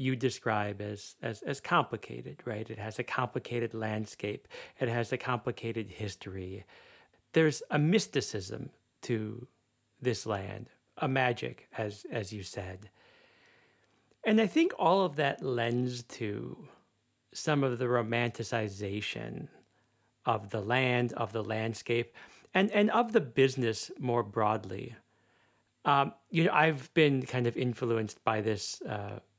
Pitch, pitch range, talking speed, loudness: 120 Hz, 110-135 Hz, 135 wpm, -32 LUFS